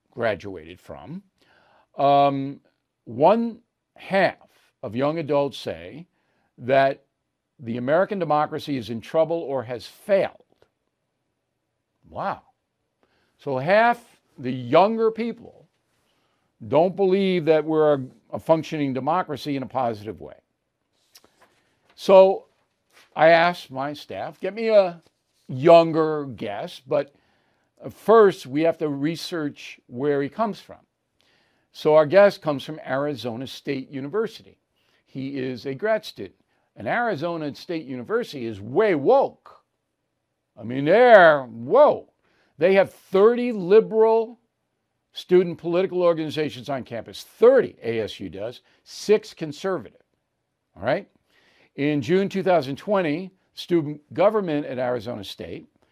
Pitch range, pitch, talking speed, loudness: 135-190 Hz, 155 Hz, 110 wpm, -22 LUFS